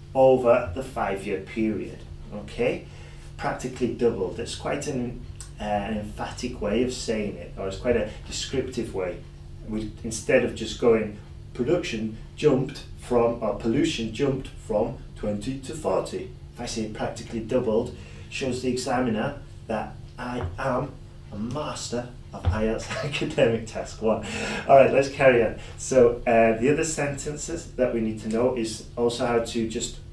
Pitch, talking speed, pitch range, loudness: 115 Hz, 150 wpm, 110-125 Hz, -26 LUFS